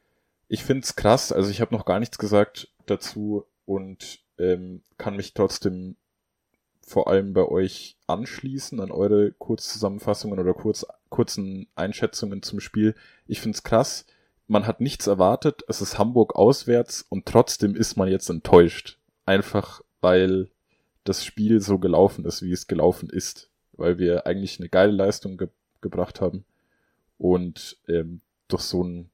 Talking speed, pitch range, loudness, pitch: 150 wpm, 90-105 Hz, -23 LUFS, 95 Hz